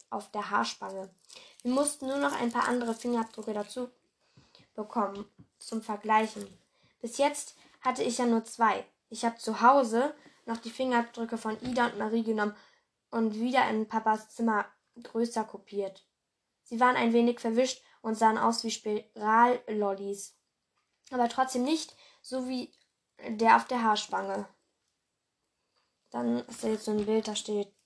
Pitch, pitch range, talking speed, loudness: 225 Hz, 215-245 Hz, 150 wpm, -30 LUFS